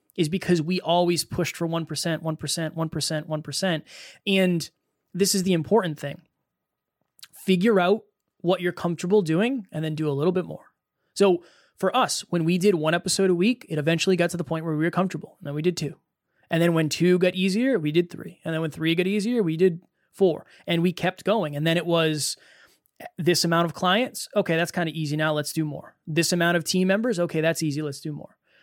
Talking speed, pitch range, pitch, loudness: 220 wpm, 160-190 Hz, 170 Hz, -24 LUFS